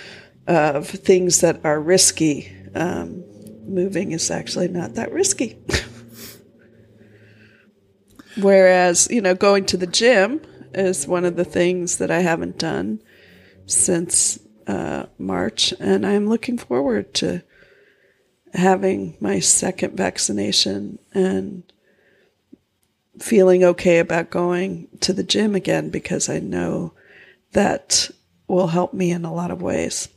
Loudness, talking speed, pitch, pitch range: -19 LUFS, 120 wpm, 180 Hz, 140-190 Hz